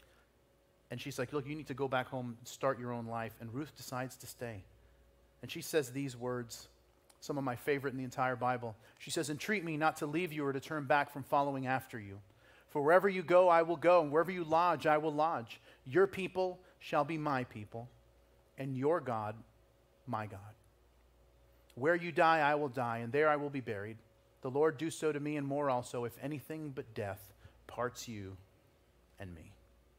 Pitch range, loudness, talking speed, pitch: 110-150 Hz, -35 LUFS, 205 wpm, 130 Hz